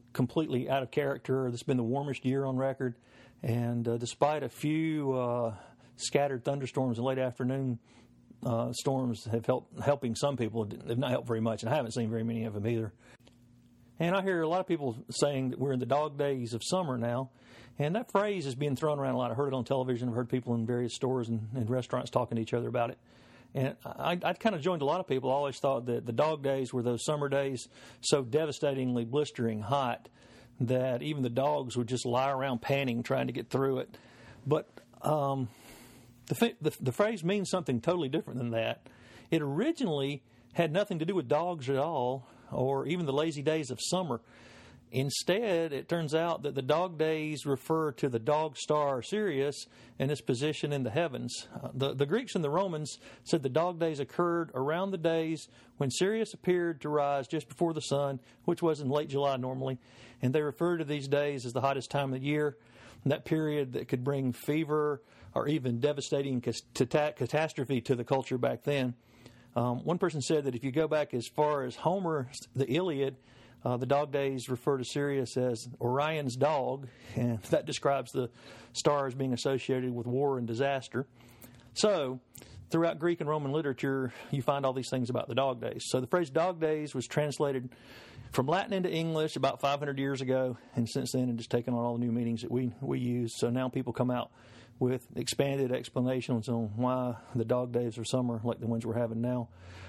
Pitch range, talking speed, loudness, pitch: 120-150 Hz, 205 wpm, -32 LUFS, 135 Hz